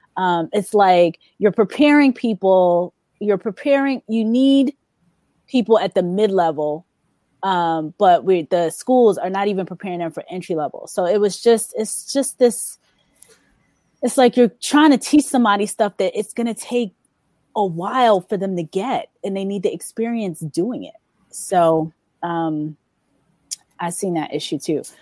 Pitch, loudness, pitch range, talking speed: 200 Hz, -18 LUFS, 175-240 Hz, 165 wpm